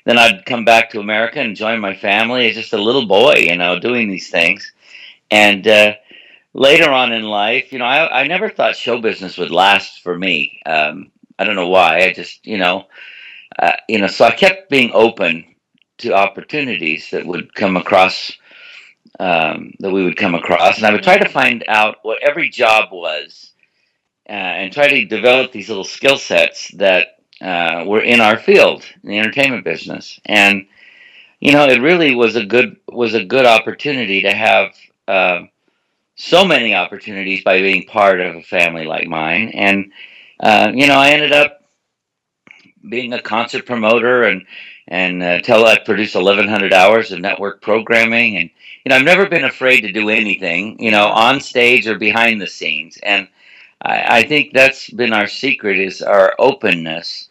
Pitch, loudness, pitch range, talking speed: 110 Hz, -13 LUFS, 100-125 Hz, 185 wpm